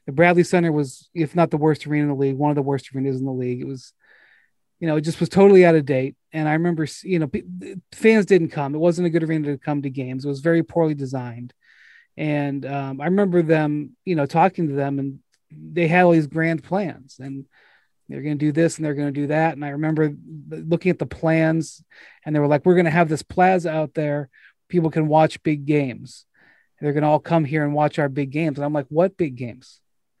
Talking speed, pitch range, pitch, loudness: 245 wpm, 145-165 Hz, 155 Hz, -20 LUFS